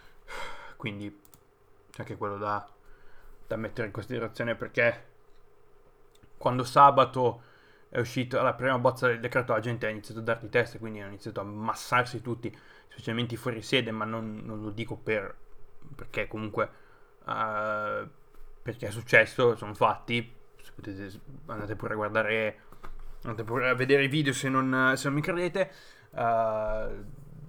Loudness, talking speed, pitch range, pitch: -29 LUFS, 145 wpm, 110-135 Hz, 115 Hz